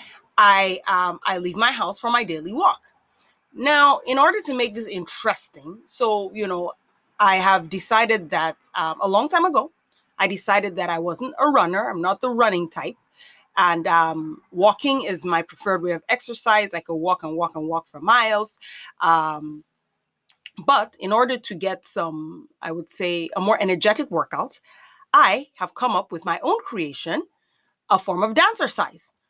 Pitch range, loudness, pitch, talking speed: 170-250 Hz, -21 LUFS, 195 Hz, 175 wpm